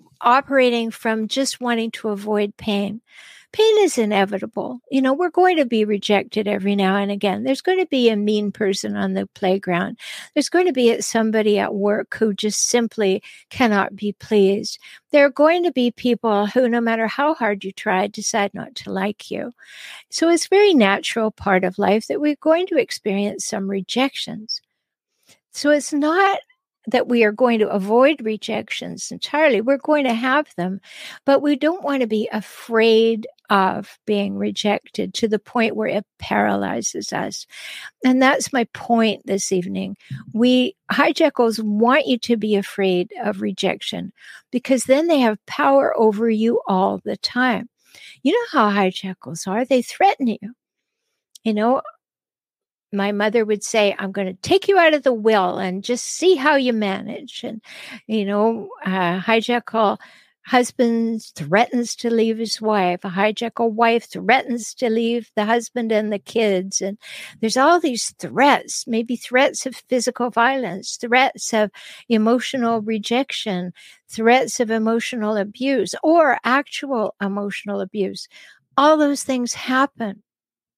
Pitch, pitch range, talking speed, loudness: 225 Hz, 205-260 Hz, 155 wpm, -19 LUFS